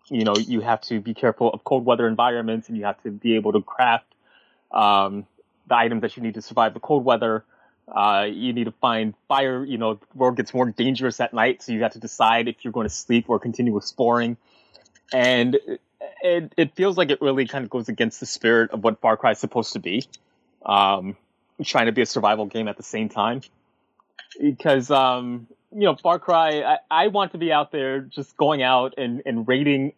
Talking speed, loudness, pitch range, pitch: 220 wpm, -22 LUFS, 110-135 Hz, 120 Hz